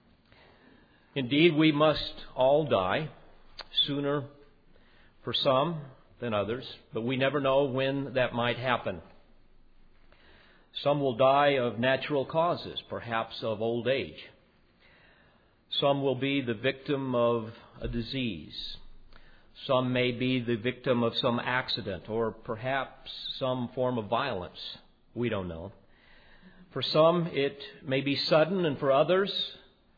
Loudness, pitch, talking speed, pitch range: -29 LUFS, 130 Hz, 125 wpm, 120-140 Hz